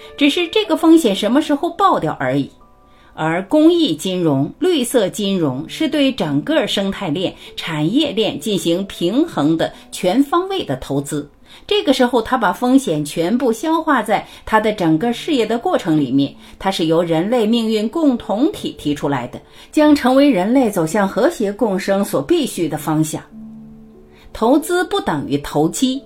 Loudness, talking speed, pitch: -17 LUFS, 245 characters per minute, 205 Hz